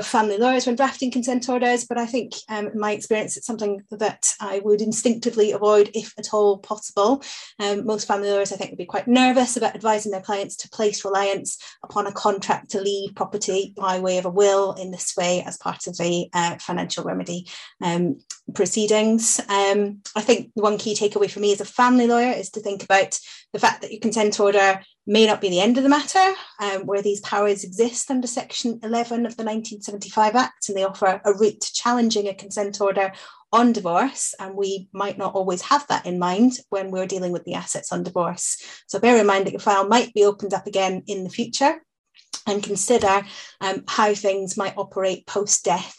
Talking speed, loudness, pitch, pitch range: 205 wpm, -22 LUFS, 205 Hz, 195-230 Hz